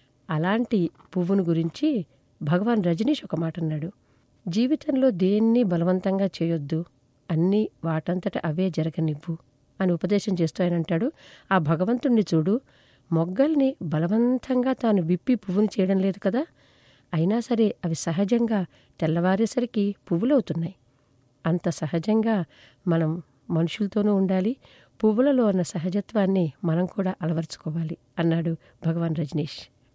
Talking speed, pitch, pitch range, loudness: 100 wpm, 180 Hz, 165-210 Hz, -25 LUFS